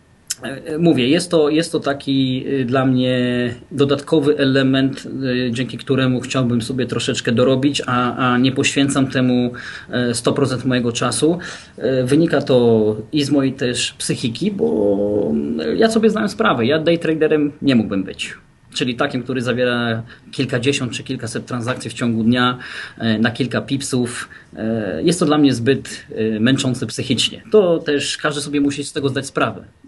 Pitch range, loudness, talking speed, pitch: 125-145 Hz, -18 LUFS, 145 wpm, 130 Hz